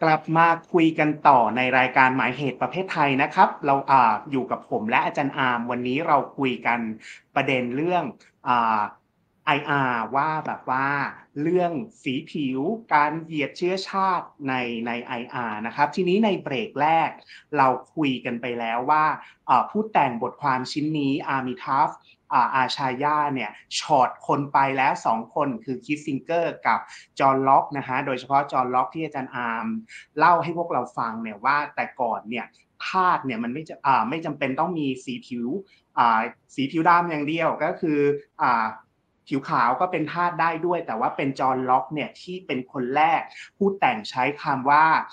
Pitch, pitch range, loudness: 140 Hz, 130-160 Hz, -23 LUFS